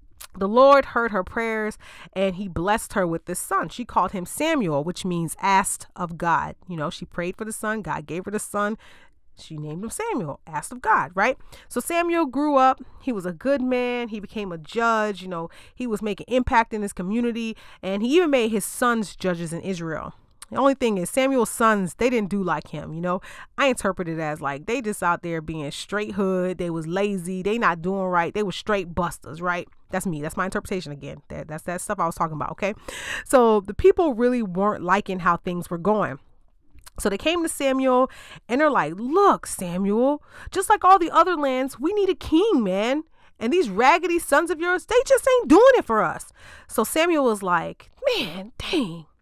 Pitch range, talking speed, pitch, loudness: 180-265 Hz, 210 wpm, 210 Hz, -23 LUFS